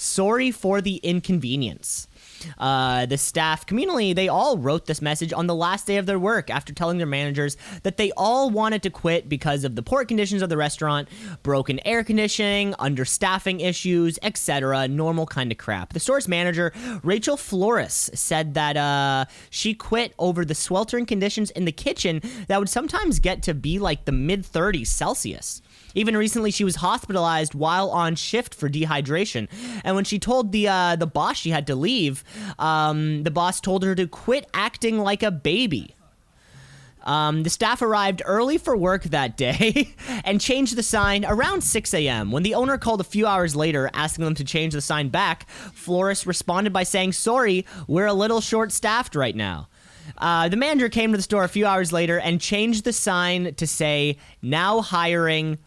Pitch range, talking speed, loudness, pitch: 155-210 Hz, 185 wpm, -22 LUFS, 180 Hz